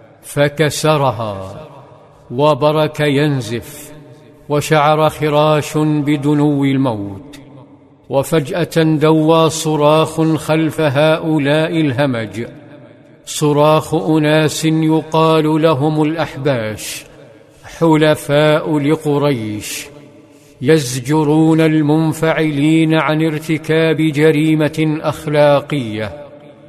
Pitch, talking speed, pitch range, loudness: 150 Hz, 60 wpm, 145-155 Hz, -14 LUFS